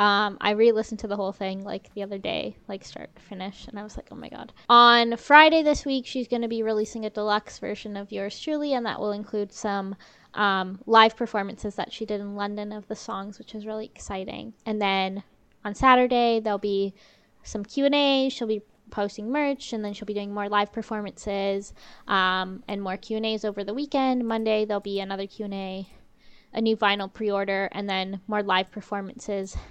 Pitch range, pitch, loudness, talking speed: 200-225 Hz, 210 Hz, -25 LUFS, 200 wpm